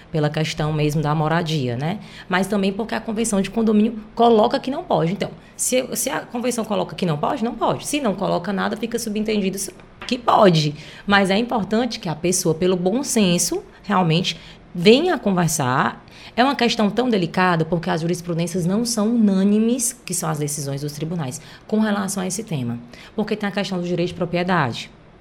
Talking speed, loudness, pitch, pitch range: 185 wpm, -20 LUFS, 190 Hz, 170-220 Hz